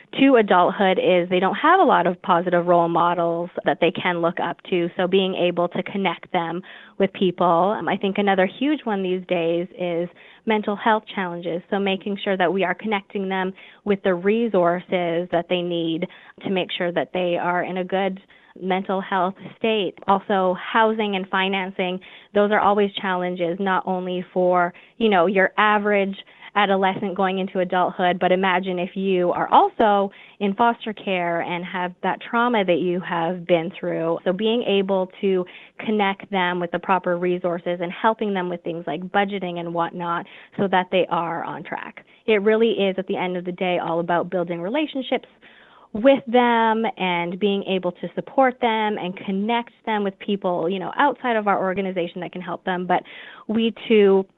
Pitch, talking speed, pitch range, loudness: 185 Hz, 180 wpm, 175-205 Hz, -22 LUFS